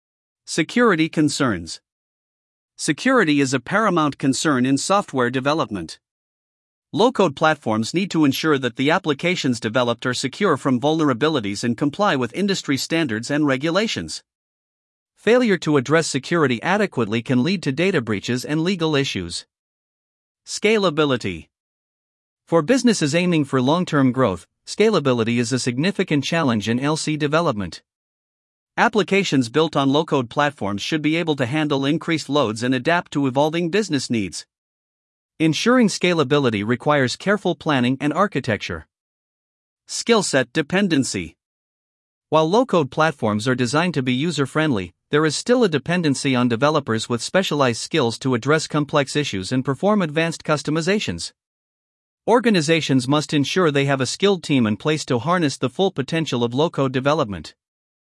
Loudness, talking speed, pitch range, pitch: -20 LUFS, 135 wpm, 125-165 Hz, 145 Hz